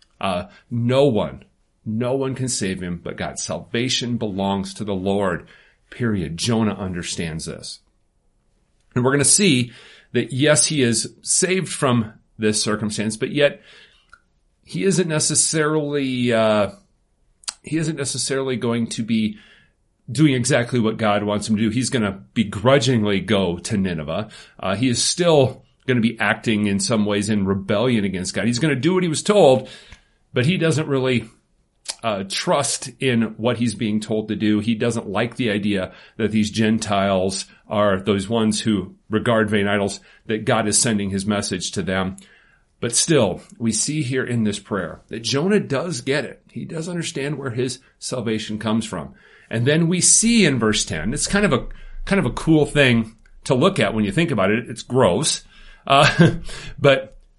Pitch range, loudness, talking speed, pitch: 105-140 Hz, -20 LUFS, 170 wpm, 115 Hz